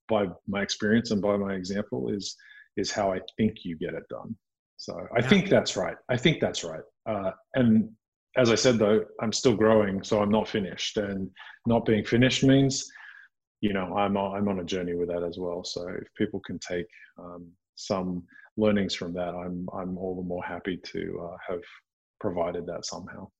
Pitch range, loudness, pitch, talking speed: 90-110 Hz, -27 LUFS, 100 Hz, 195 wpm